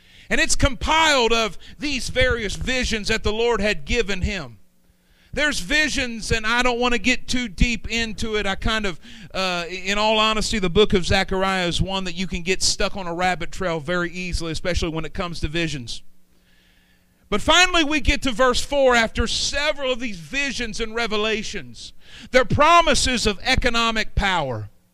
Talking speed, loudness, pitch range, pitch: 180 wpm, -21 LUFS, 175-245 Hz, 210 Hz